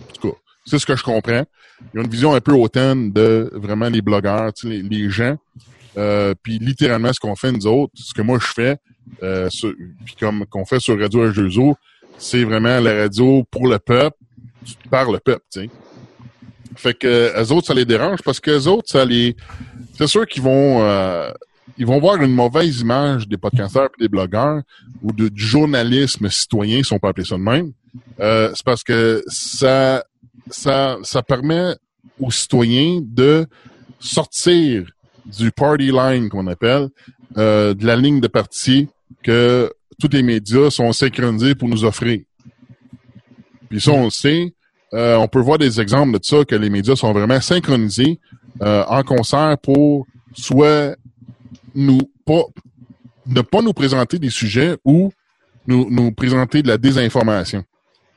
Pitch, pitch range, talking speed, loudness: 125 Hz, 115-135 Hz, 170 wpm, -16 LUFS